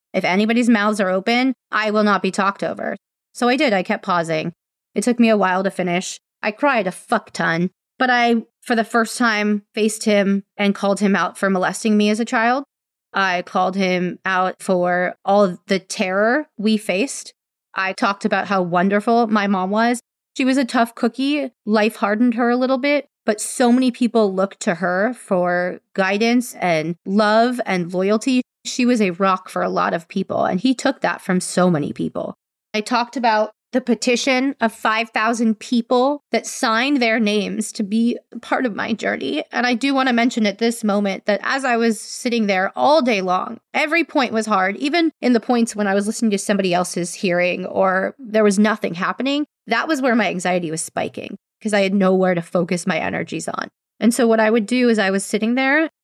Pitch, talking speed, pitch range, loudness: 215 Hz, 205 wpm, 190-240 Hz, -19 LUFS